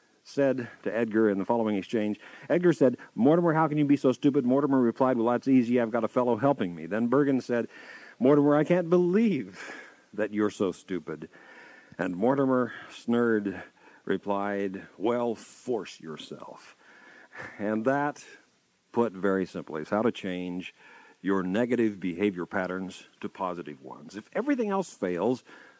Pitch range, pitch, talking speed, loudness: 100-135 Hz, 115 Hz, 150 wpm, -27 LUFS